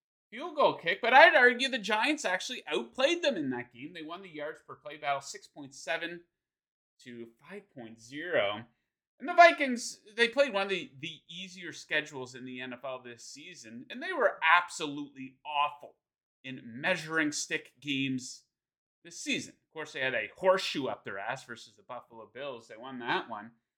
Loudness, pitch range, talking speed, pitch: -29 LUFS, 130-200 Hz, 170 wpm, 155 Hz